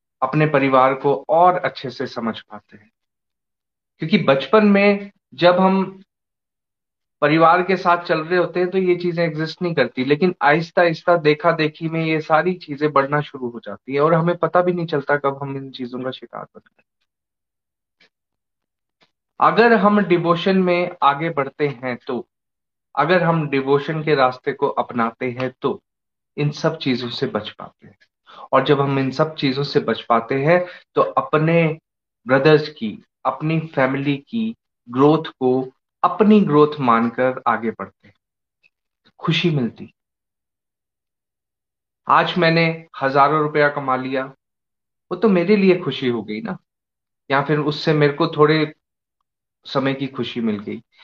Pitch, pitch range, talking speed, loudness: 145 Hz, 130-170 Hz, 155 wpm, -18 LUFS